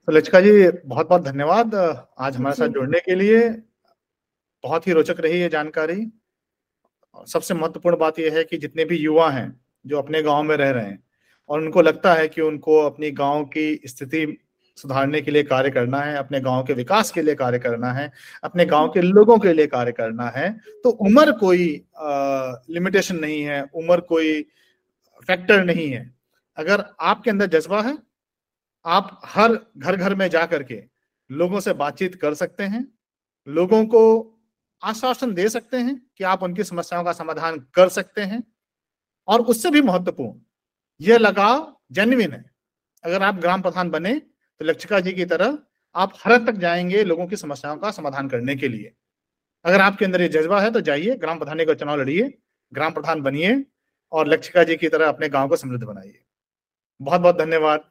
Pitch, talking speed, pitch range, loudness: 170 Hz, 180 wpm, 150-200 Hz, -20 LUFS